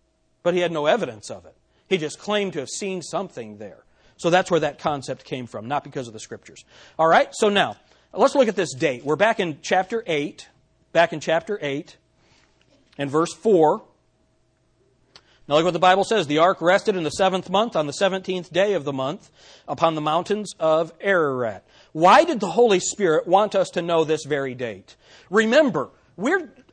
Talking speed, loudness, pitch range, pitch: 195 wpm, -21 LUFS, 150-195 Hz, 175 Hz